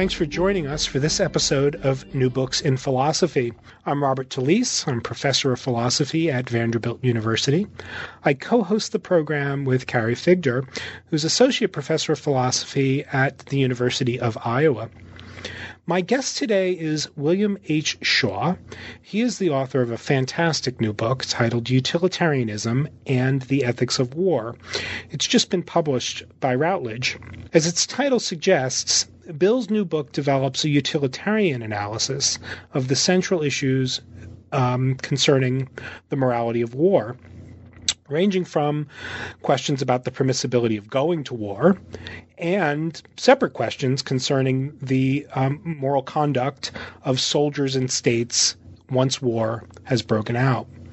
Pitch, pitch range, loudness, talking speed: 135 Hz, 120-160 Hz, -22 LUFS, 135 wpm